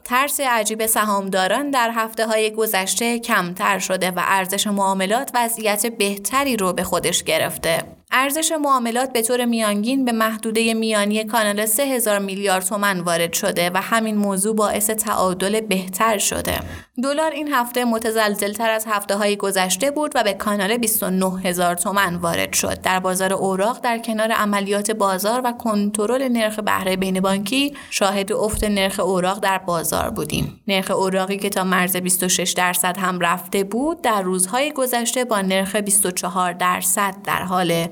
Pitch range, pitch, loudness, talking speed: 190-230 Hz, 205 Hz, -19 LUFS, 150 wpm